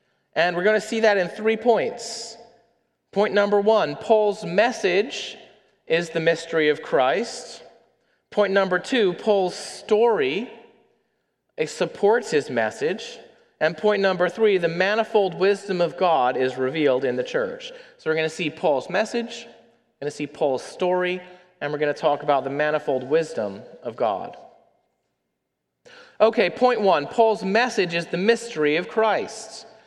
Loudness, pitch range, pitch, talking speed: -22 LUFS, 170-230 Hz, 205 Hz, 150 wpm